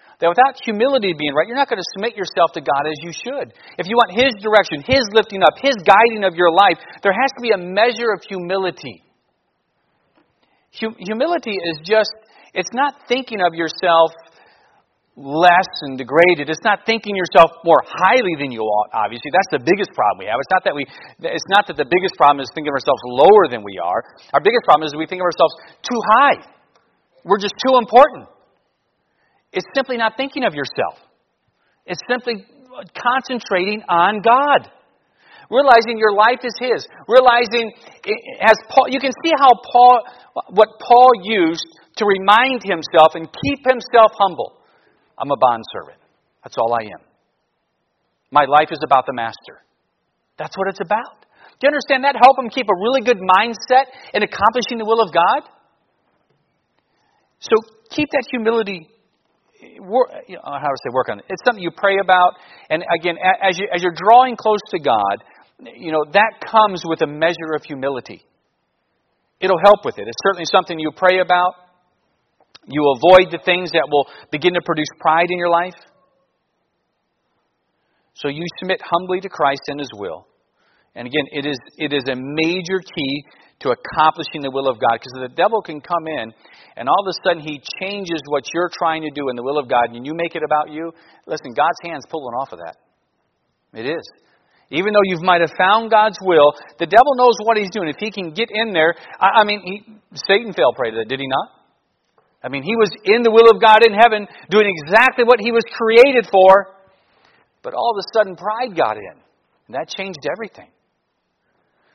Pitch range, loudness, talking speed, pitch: 160-230 Hz, -16 LUFS, 190 wpm, 190 Hz